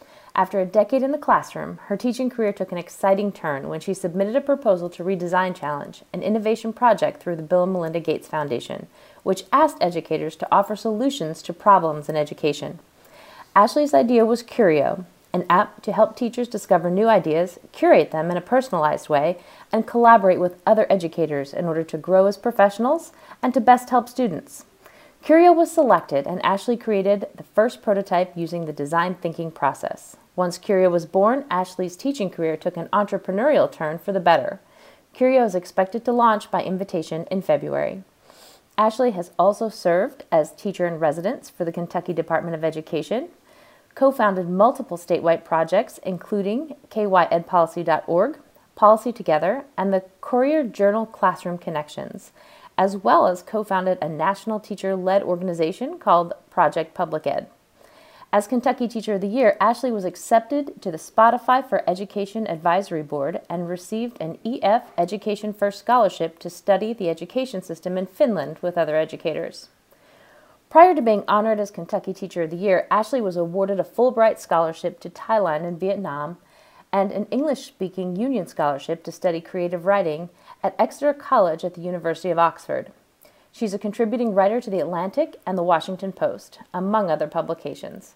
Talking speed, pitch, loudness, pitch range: 165 wpm, 195 Hz, -21 LUFS, 175-225 Hz